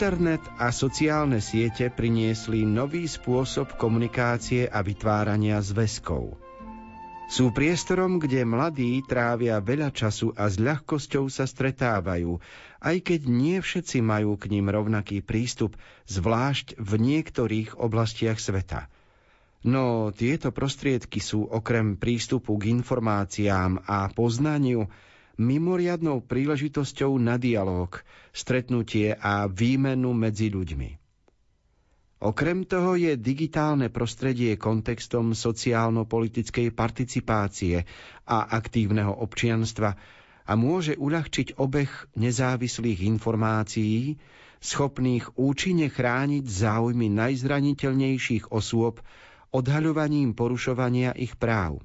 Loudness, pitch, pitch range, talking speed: -26 LUFS, 120 Hz, 110-135 Hz, 95 wpm